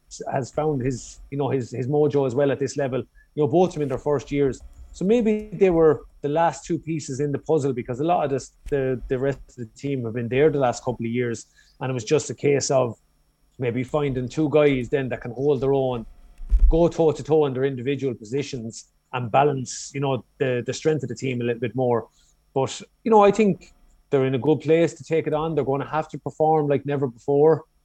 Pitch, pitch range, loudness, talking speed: 140 Hz, 130-150 Hz, -23 LUFS, 240 wpm